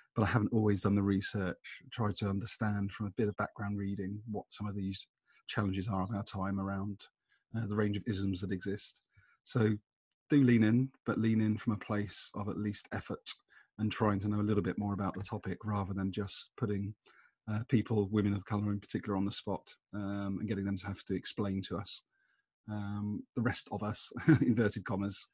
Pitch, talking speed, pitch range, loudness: 105 Hz, 210 wpm, 100-105 Hz, -35 LUFS